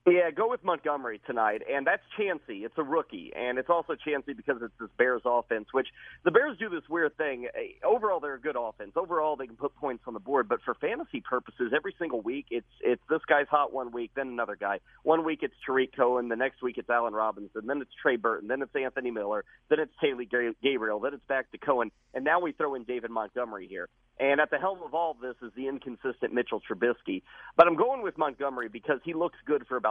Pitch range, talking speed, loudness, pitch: 120-155 Hz, 235 wpm, -30 LUFS, 135 Hz